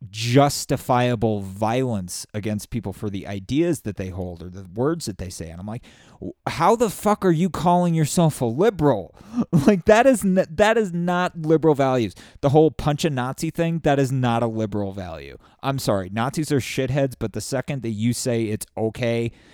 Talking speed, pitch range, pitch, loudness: 190 wpm, 110-160 Hz, 130 Hz, -22 LUFS